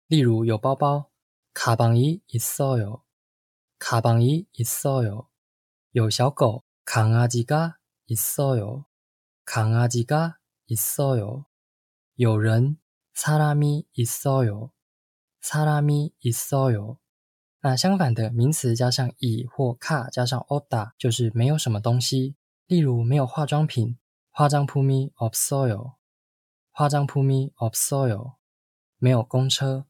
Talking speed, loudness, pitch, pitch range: 195 characters per minute, -23 LUFS, 125 Hz, 115-140 Hz